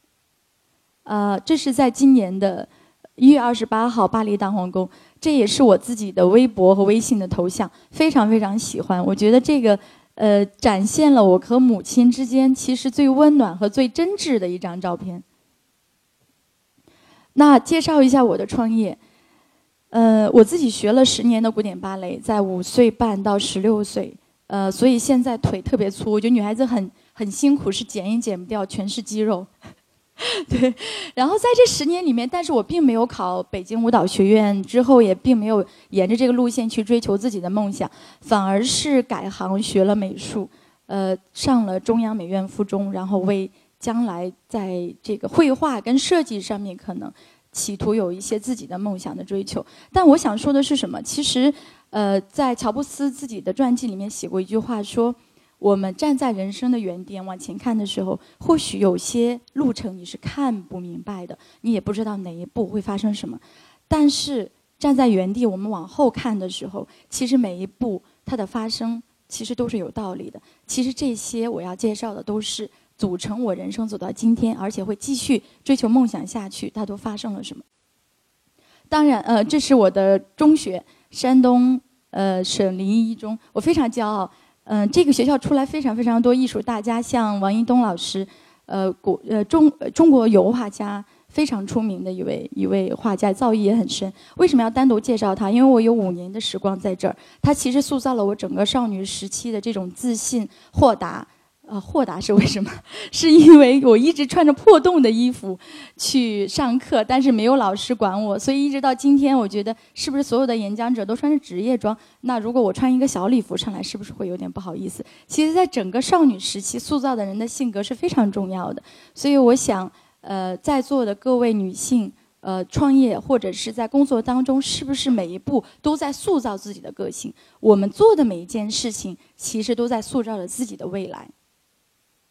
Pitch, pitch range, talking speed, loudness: 230 Hz, 200-260 Hz, 285 characters per minute, -19 LUFS